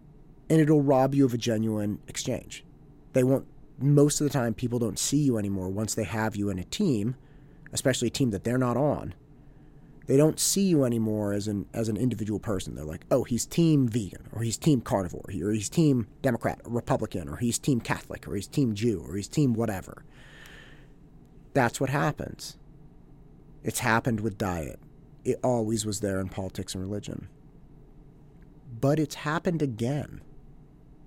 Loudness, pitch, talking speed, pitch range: -27 LUFS, 130 Hz, 175 wpm, 110-145 Hz